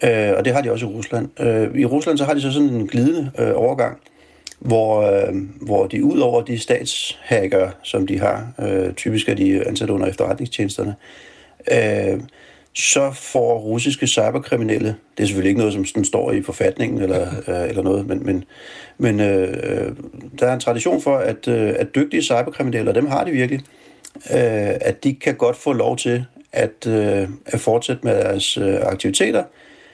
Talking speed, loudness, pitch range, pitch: 180 wpm, -19 LUFS, 100-130 Hz, 115 Hz